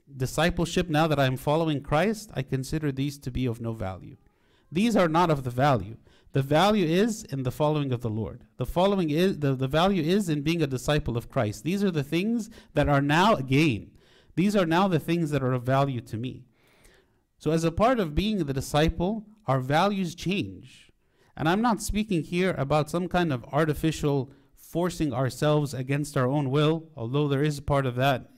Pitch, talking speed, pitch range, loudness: 150 Hz, 200 wpm, 135-175 Hz, -26 LUFS